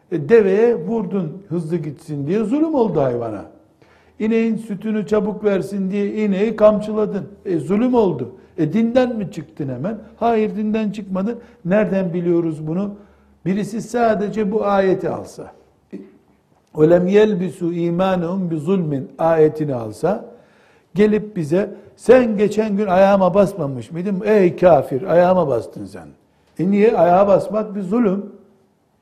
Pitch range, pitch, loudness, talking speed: 175-215 Hz, 200 Hz, -18 LUFS, 125 wpm